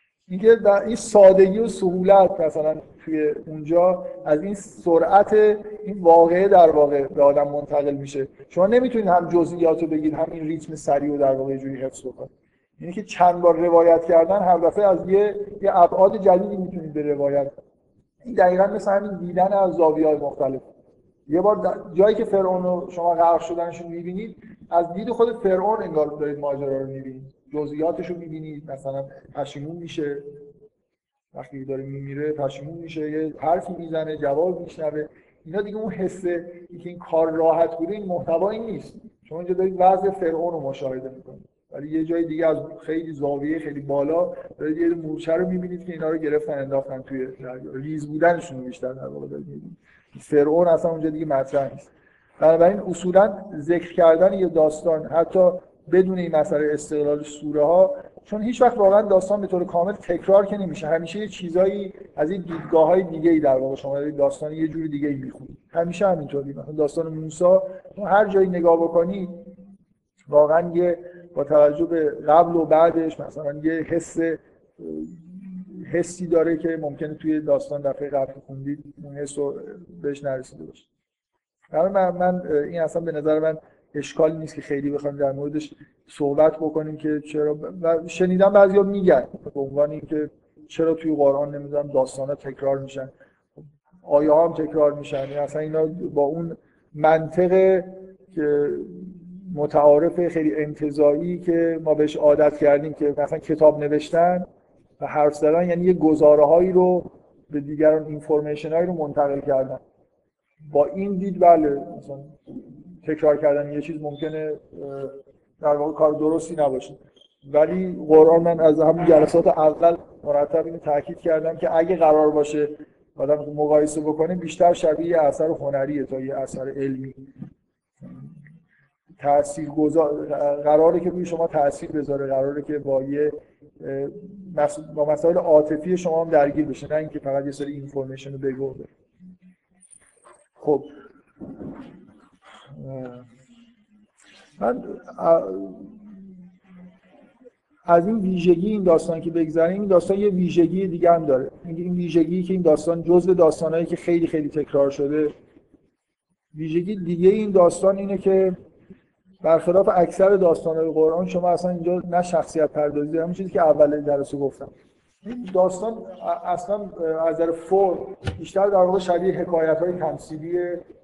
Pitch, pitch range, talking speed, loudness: 160 Hz, 145-180 Hz, 150 wpm, -21 LUFS